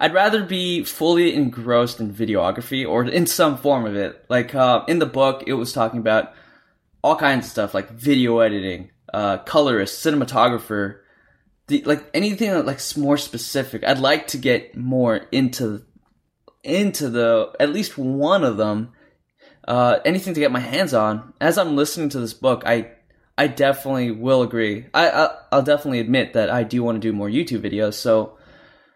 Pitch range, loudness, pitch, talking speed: 115-145 Hz, -20 LUFS, 125 Hz, 175 wpm